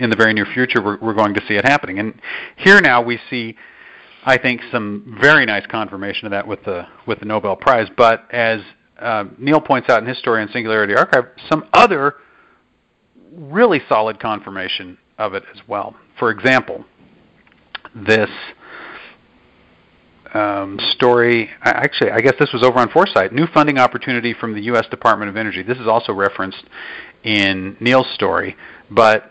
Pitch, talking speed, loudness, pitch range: 115 Hz, 165 wpm, -16 LUFS, 100-125 Hz